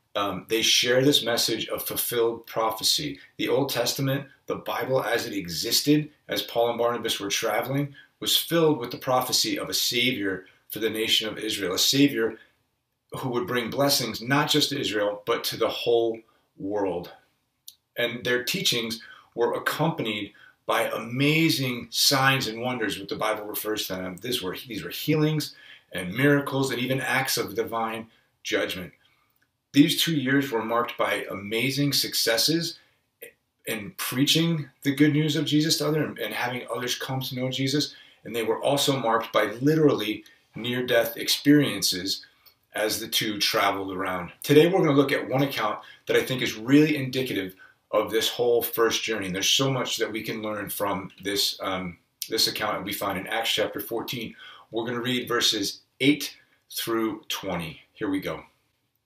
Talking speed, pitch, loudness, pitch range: 170 wpm, 120 Hz, -25 LUFS, 110-140 Hz